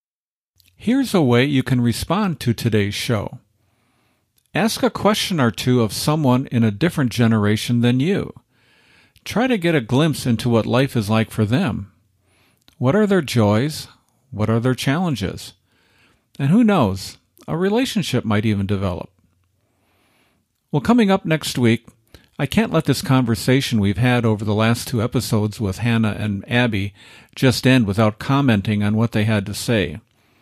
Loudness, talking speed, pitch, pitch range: -19 LUFS, 160 wpm, 120 Hz, 105-135 Hz